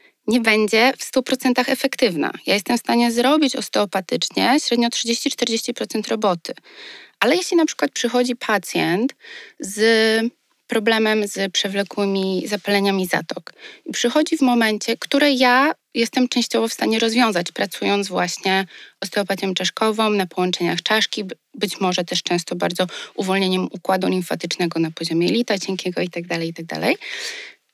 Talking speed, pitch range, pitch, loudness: 130 wpm, 195-250 Hz, 225 Hz, -20 LUFS